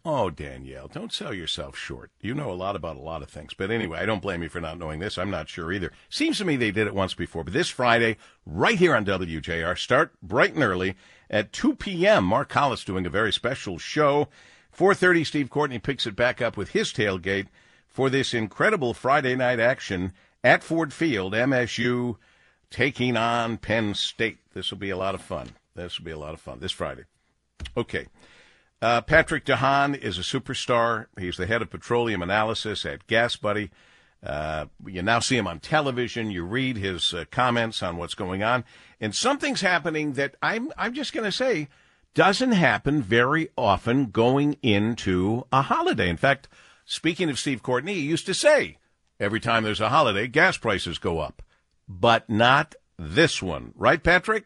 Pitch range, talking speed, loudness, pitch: 95-140 Hz, 190 wpm, -24 LUFS, 115 Hz